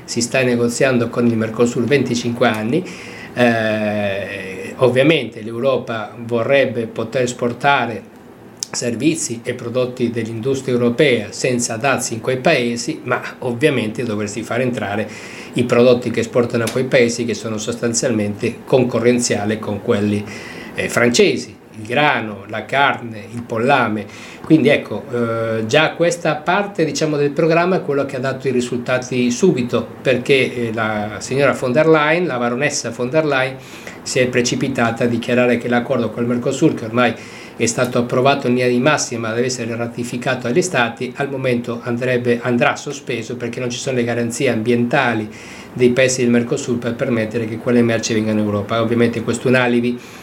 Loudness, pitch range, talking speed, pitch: -17 LUFS, 115-130 Hz, 155 wpm, 120 Hz